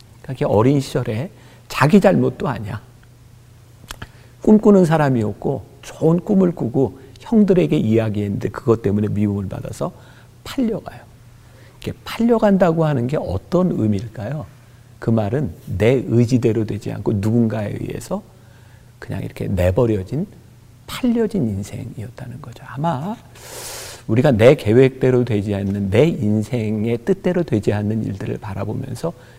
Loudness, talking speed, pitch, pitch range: -18 LUFS, 290 characters per minute, 120 Hz, 110-140 Hz